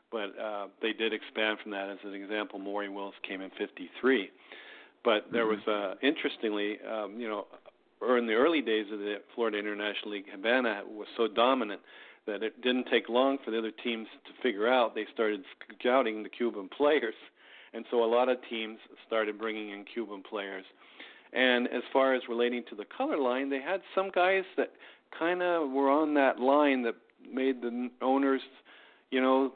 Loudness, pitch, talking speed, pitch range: -31 LUFS, 115 Hz, 185 wpm, 105-130 Hz